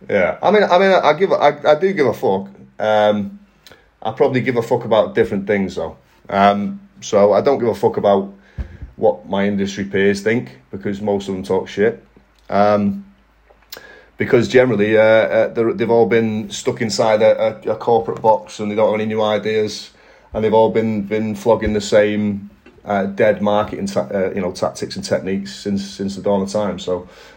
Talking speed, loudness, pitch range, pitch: 200 wpm, -17 LUFS, 100-110 Hz, 105 Hz